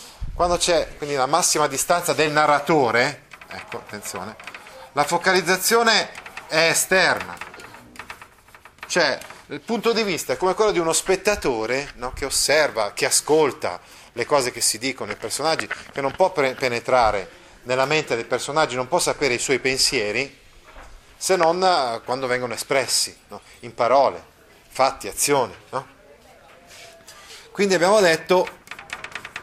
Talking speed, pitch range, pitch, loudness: 135 wpm, 130-185 Hz, 155 Hz, -20 LUFS